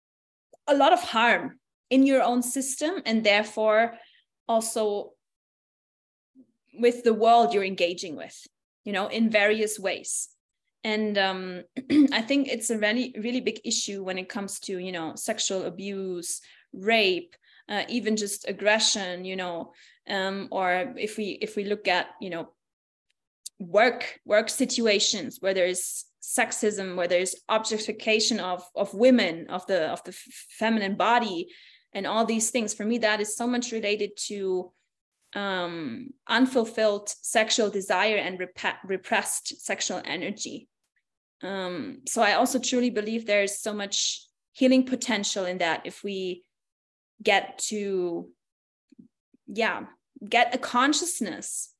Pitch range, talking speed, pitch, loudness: 190-240 Hz, 140 wpm, 215 Hz, -26 LUFS